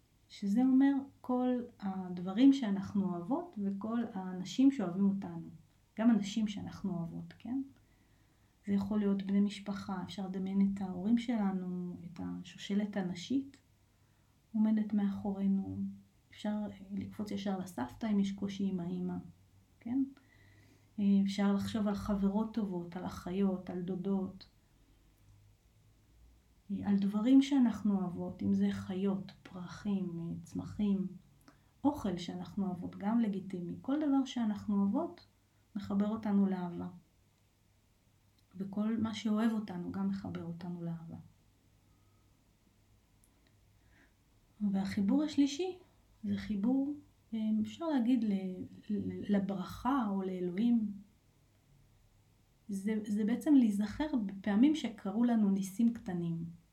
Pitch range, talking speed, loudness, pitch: 165-215 Hz, 100 wpm, -35 LUFS, 195 Hz